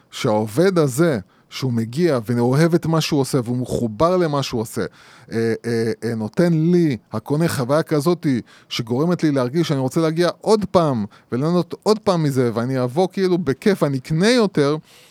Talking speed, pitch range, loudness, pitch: 165 wpm, 120-170 Hz, -19 LUFS, 150 Hz